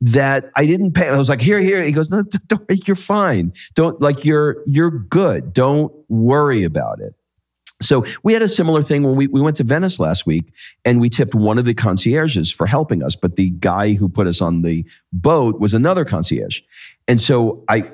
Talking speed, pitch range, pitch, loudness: 215 wpm, 105-155 Hz, 135 Hz, -16 LUFS